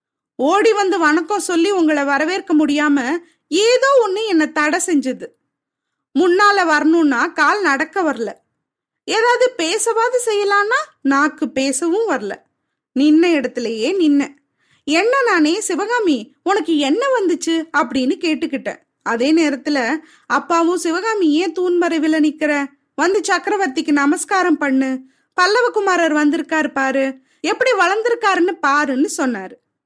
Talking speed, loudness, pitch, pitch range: 105 wpm, -16 LUFS, 320 Hz, 290-385 Hz